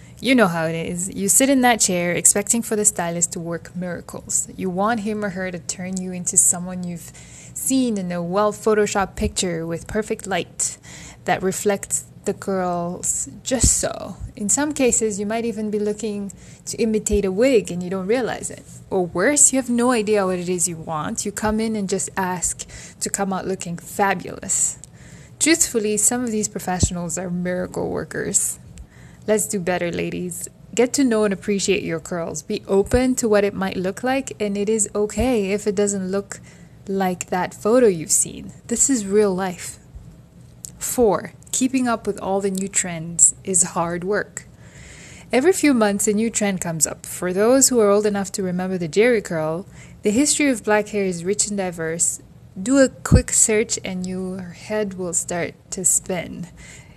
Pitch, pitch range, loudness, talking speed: 200 Hz, 180-215 Hz, -20 LUFS, 185 wpm